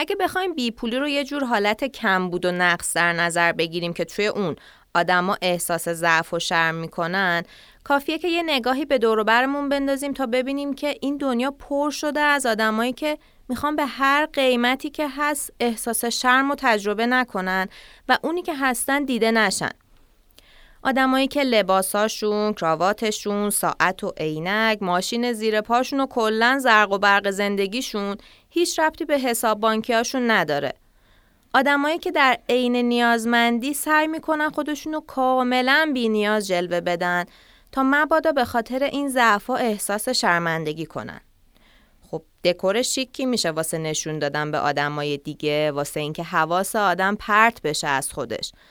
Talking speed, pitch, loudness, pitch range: 150 wpm, 230 Hz, -21 LUFS, 185-275 Hz